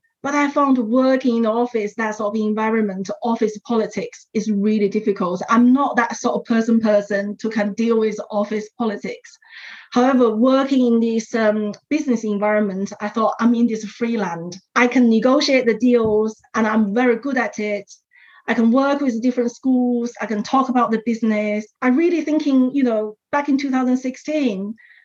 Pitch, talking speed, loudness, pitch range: 230 Hz, 180 wpm, -19 LUFS, 215-255 Hz